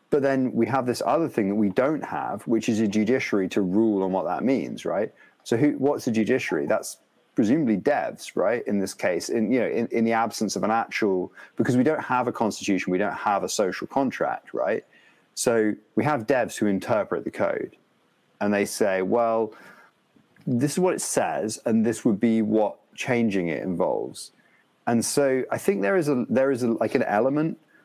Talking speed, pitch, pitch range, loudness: 205 wpm, 115 Hz, 105-125 Hz, -24 LUFS